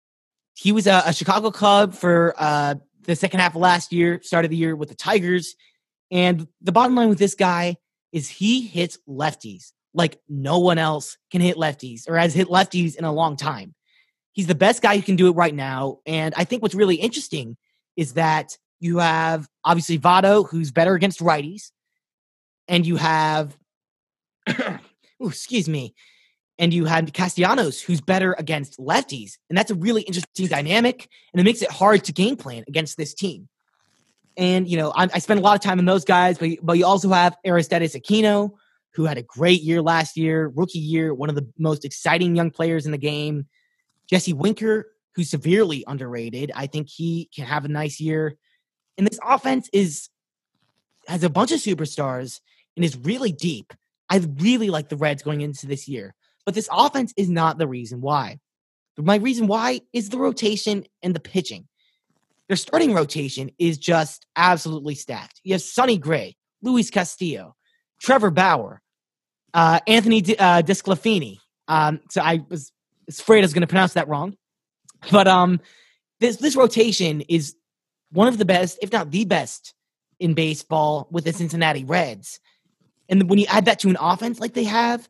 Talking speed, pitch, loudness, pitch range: 180 wpm, 175 Hz, -20 LUFS, 155-200 Hz